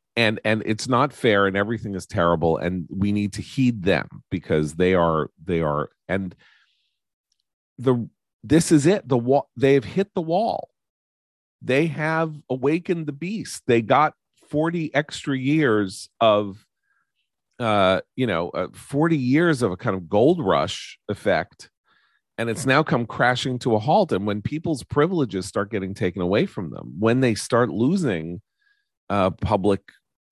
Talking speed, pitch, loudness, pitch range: 155 wpm, 115 Hz, -22 LUFS, 95-150 Hz